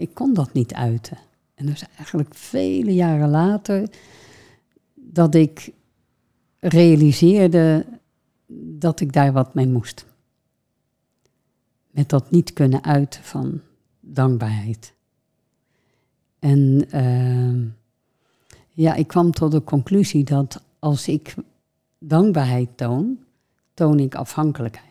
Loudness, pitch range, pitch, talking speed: -19 LUFS, 130-165 Hz, 145 Hz, 105 wpm